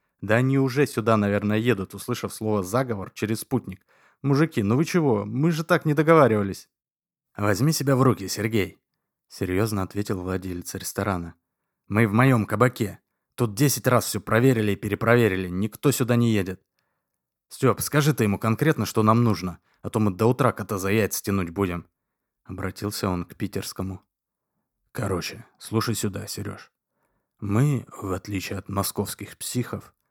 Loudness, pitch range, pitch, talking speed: -24 LUFS, 100-125 Hz, 110 Hz, 150 wpm